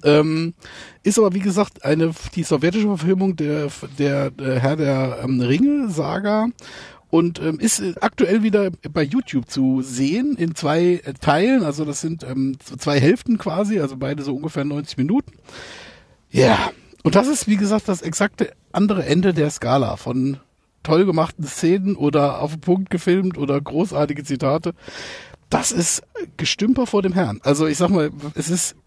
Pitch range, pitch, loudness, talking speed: 140-195 Hz, 160 Hz, -20 LUFS, 165 wpm